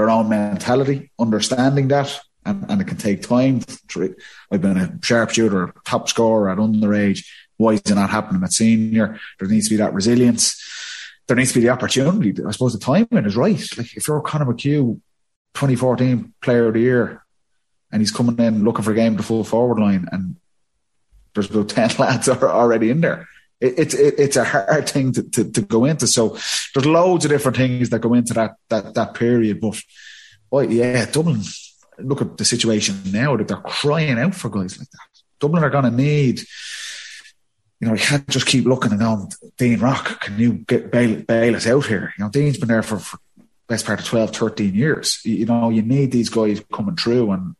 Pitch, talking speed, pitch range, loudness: 120 Hz, 205 wpm, 110-135 Hz, -18 LUFS